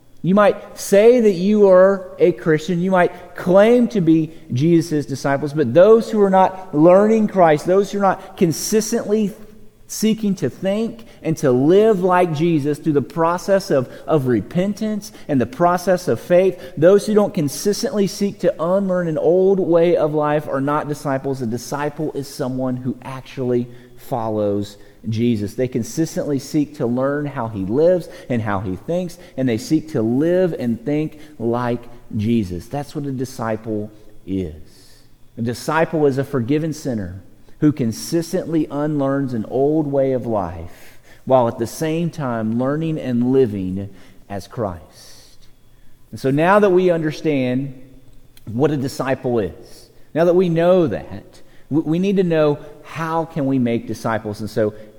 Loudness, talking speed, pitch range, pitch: -18 LUFS, 160 wpm, 120-180 Hz, 150 Hz